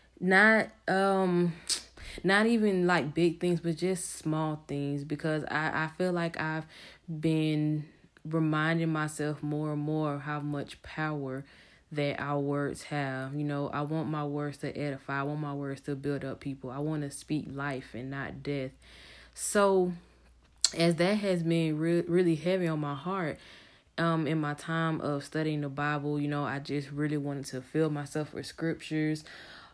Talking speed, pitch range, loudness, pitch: 170 wpm, 145-165 Hz, -31 LUFS, 150 Hz